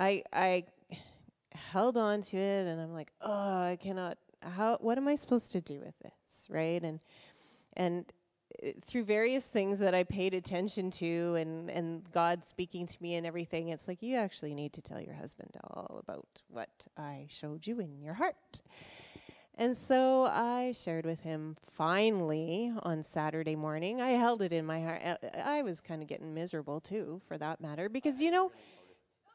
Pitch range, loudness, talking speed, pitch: 165-220 Hz, -35 LUFS, 180 wpm, 180 Hz